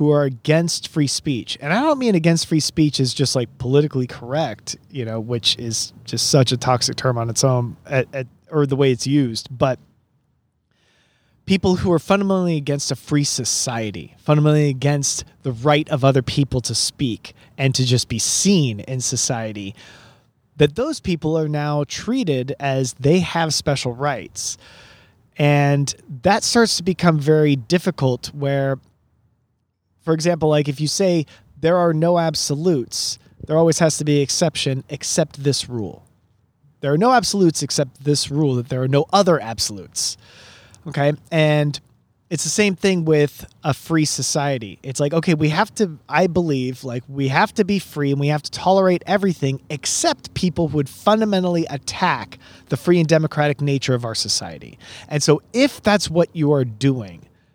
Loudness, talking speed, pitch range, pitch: -19 LUFS, 170 wpm, 125-160 Hz, 145 Hz